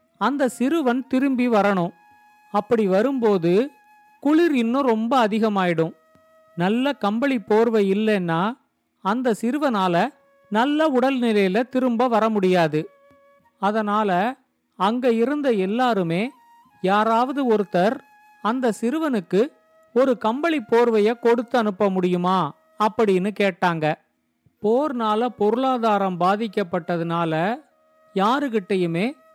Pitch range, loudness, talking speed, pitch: 195-265 Hz, -21 LUFS, 85 wpm, 225 Hz